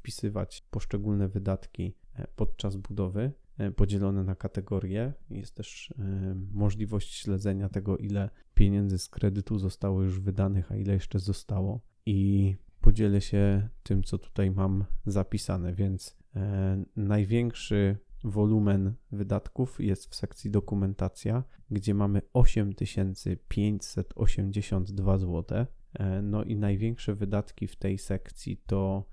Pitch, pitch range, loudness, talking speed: 100 Hz, 95-105 Hz, -30 LUFS, 110 wpm